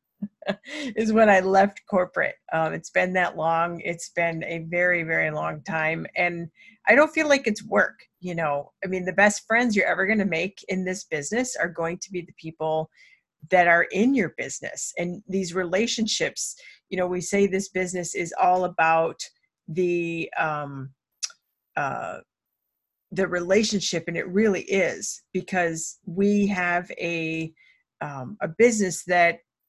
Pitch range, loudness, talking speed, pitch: 170-205 Hz, -24 LUFS, 160 wpm, 180 Hz